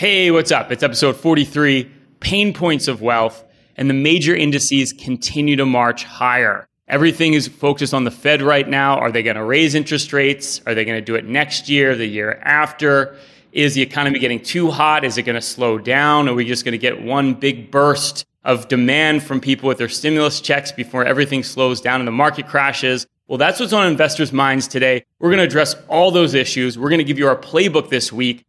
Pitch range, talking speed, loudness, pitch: 125-150 Hz, 220 wpm, -16 LUFS, 140 Hz